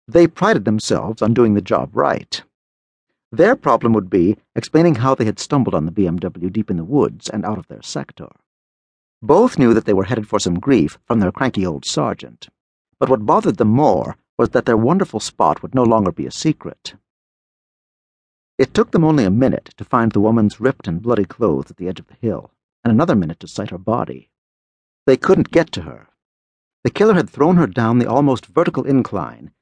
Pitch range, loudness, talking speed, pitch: 95-135 Hz, -17 LUFS, 205 wpm, 110 Hz